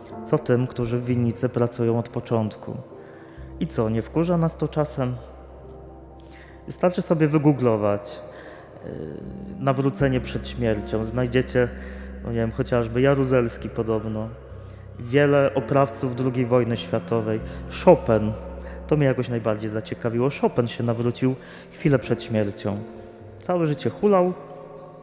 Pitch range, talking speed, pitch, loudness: 105-135 Hz, 115 wpm, 120 Hz, -23 LUFS